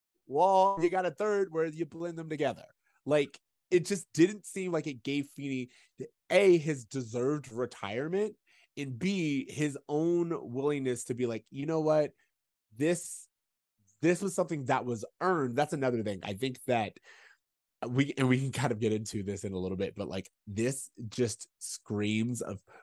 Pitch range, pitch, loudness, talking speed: 120-170 Hz, 140 Hz, -32 LUFS, 175 wpm